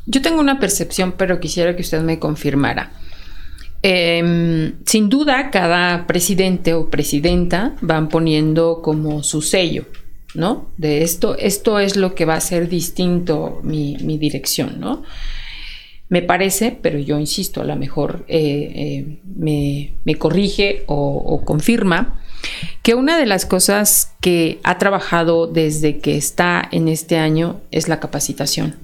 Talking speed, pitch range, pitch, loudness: 145 wpm, 150-190 Hz, 165 Hz, -17 LUFS